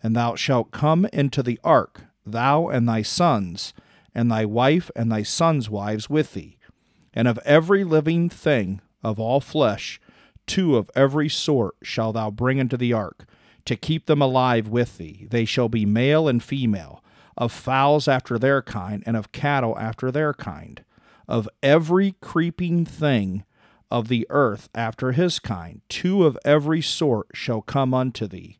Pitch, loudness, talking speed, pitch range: 125 Hz, -22 LUFS, 165 wpm, 110-150 Hz